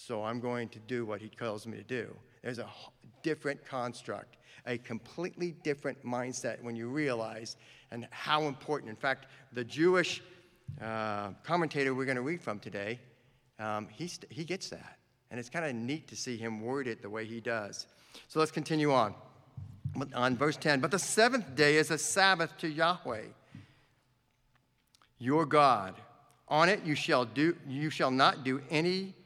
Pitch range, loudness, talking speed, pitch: 115-155 Hz, -32 LUFS, 175 wpm, 130 Hz